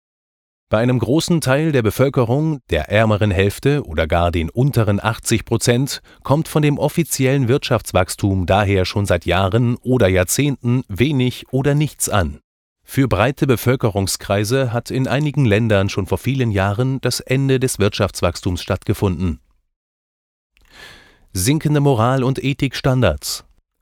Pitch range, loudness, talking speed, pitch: 95-130 Hz, -18 LUFS, 125 wpm, 120 Hz